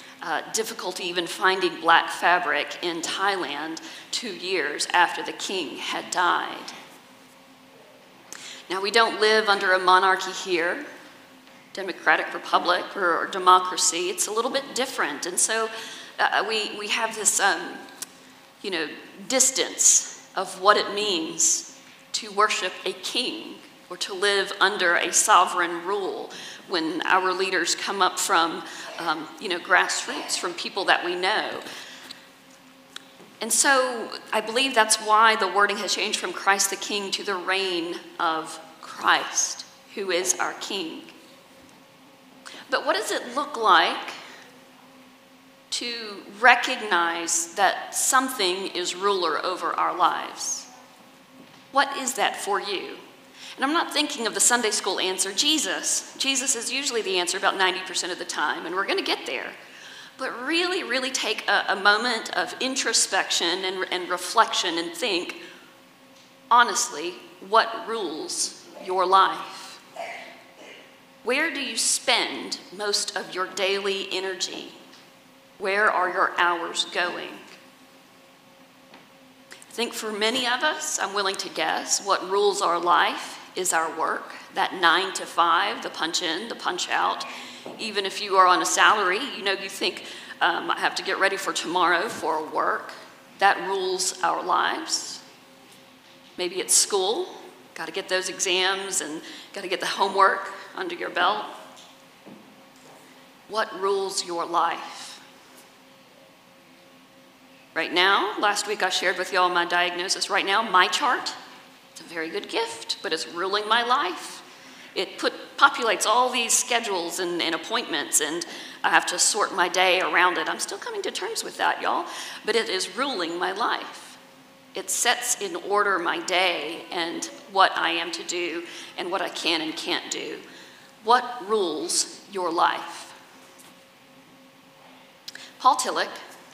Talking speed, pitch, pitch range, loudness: 145 wpm, 215 Hz, 185-270 Hz, -23 LUFS